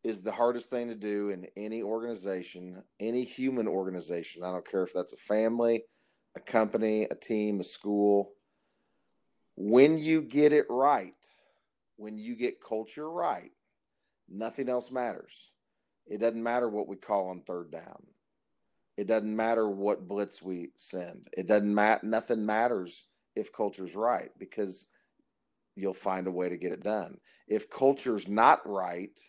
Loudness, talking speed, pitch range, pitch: -30 LUFS, 155 wpm, 100-115 Hz, 110 Hz